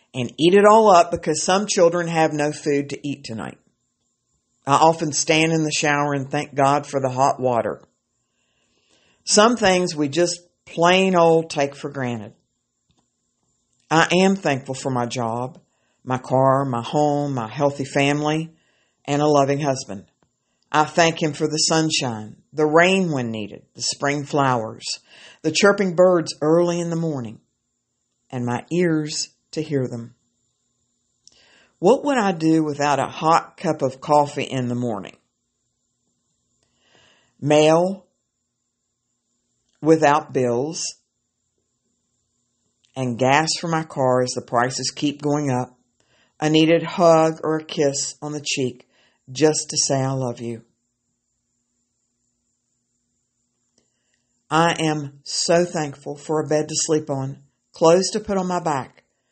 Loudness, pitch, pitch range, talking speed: -20 LUFS, 145 Hz, 125-160 Hz, 140 wpm